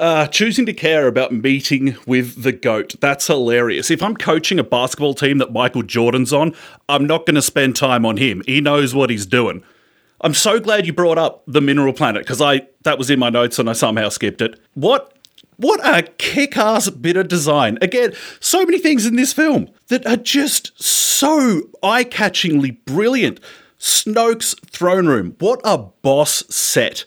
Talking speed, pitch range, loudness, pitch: 180 wpm, 135-215 Hz, -16 LUFS, 155 Hz